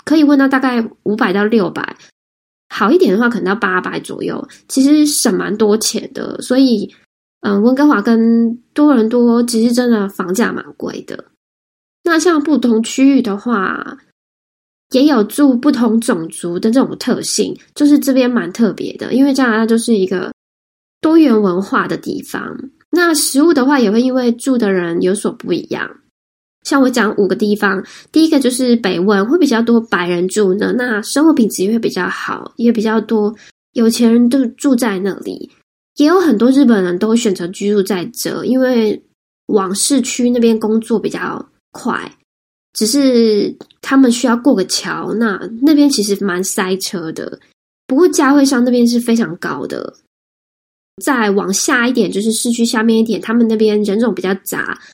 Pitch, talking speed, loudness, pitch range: 230 Hz, 250 characters per minute, -14 LUFS, 210-270 Hz